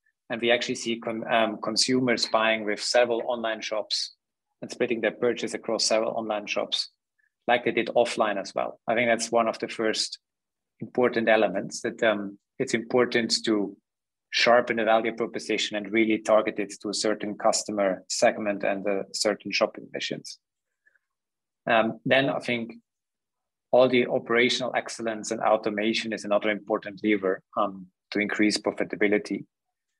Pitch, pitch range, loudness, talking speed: 110 Hz, 105-120 Hz, -26 LUFS, 155 wpm